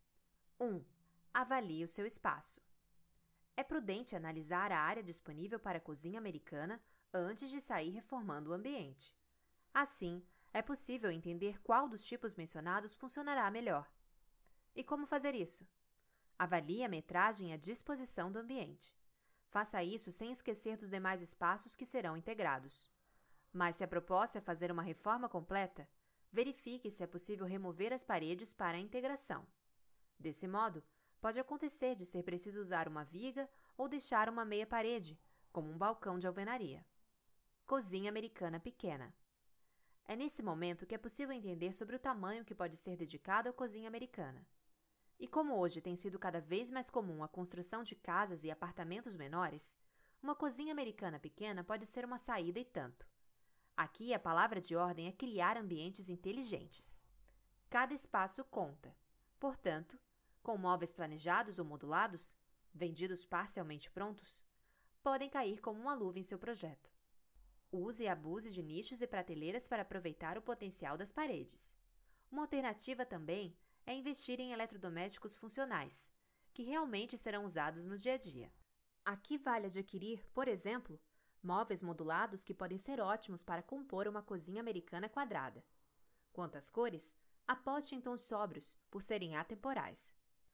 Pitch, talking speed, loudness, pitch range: 200 Hz, 150 wpm, -43 LUFS, 175-240 Hz